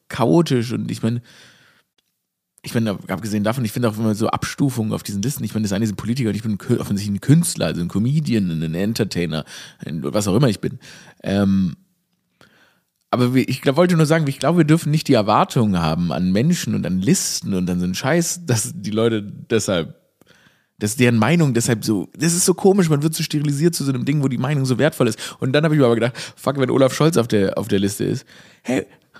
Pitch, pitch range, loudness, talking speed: 125 Hz, 105-160 Hz, -19 LUFS, 235 wpm